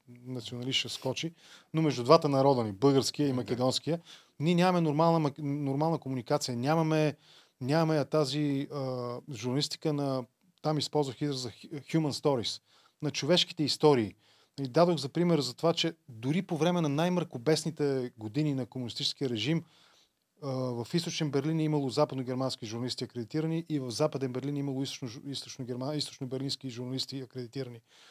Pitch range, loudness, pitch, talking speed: 130-155 Hz, -31 LUFS, 140 Hz, 140 wpm